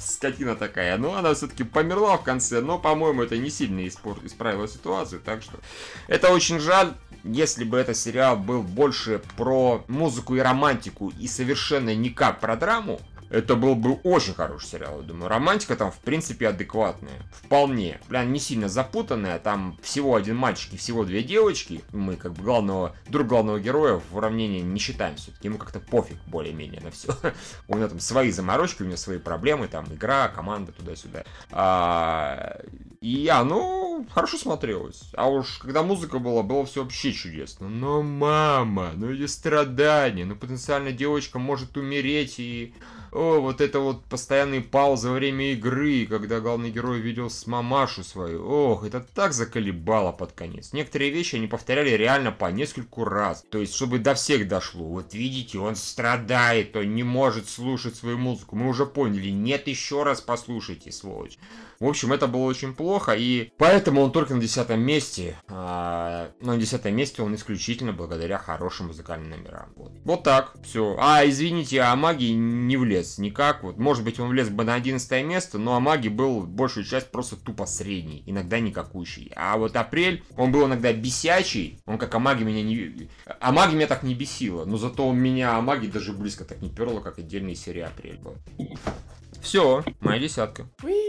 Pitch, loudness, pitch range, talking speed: 120 Hz, -24 LUFS, 105-140 Hz, 170 wpm